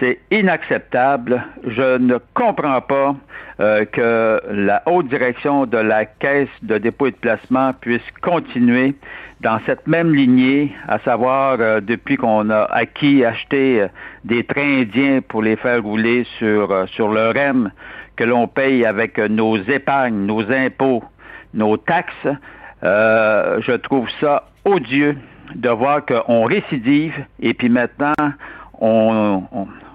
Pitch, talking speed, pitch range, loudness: 125 Hz, 140 wpm, 110-140 Hz, -17 LUFS